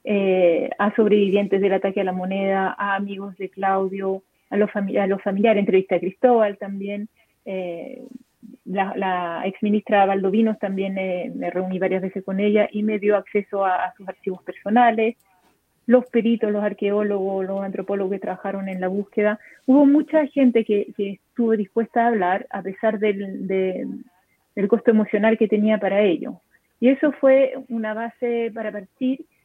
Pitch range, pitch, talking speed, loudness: 195-225 Hz, 205 Hz, 165 wpm, -21 LUFS